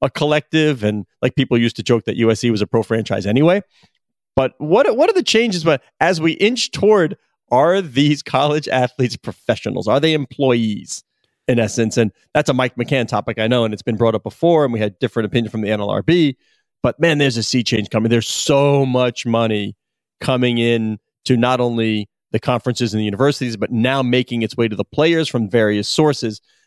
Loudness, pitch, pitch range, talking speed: -17 LUFS, 120 Hz, 115-145 Hz, 205 wpm